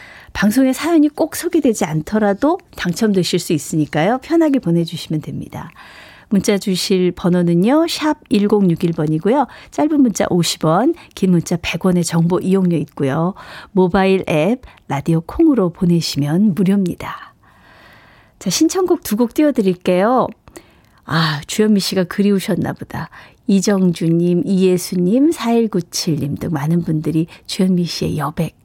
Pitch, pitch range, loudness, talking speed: 185 Hz, 170-220 Hz, -16 LUFS, 280 characters per minute